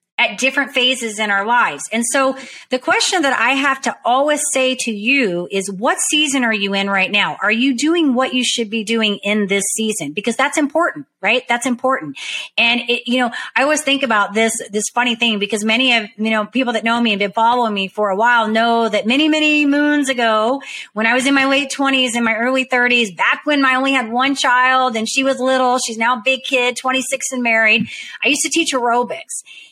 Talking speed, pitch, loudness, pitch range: 225 wpm, 250 Hz, -15 LUFS, 225-270 Hz